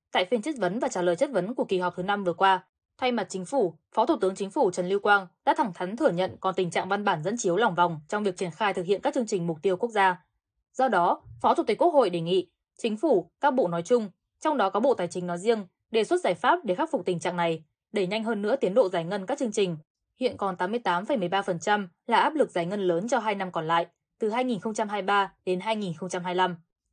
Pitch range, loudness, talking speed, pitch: 180-225 Hz, -27 LUFS, 260 wpm, 195 Hz